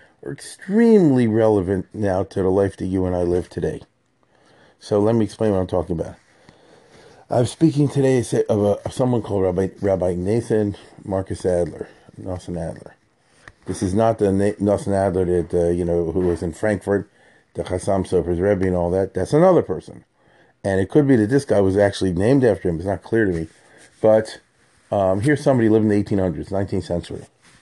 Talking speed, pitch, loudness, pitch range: 190 wpm, 100 Hz, -20 LUFS, 95-110 Hz